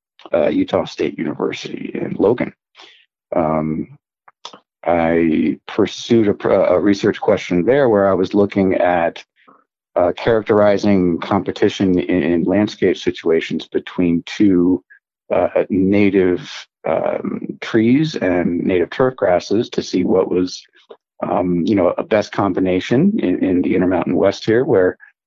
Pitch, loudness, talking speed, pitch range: 95 Hz, -17 LUFS, 125 wpm, 90-100 Hz